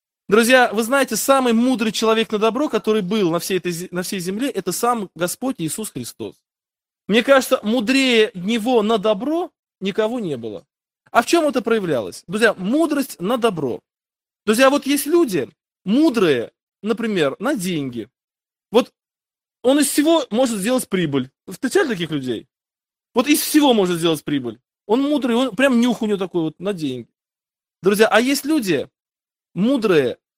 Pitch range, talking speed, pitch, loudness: 190-265 Hz, 155 wpm, 225 Hz, -19 LUFS